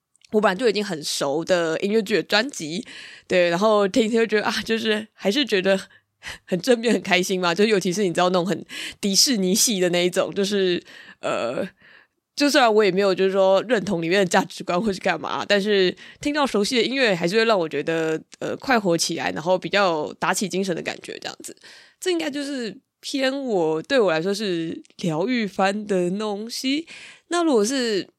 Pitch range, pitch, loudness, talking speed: 180-225 Hz, 200 Hz, -21 LUFS, 295 characters per minute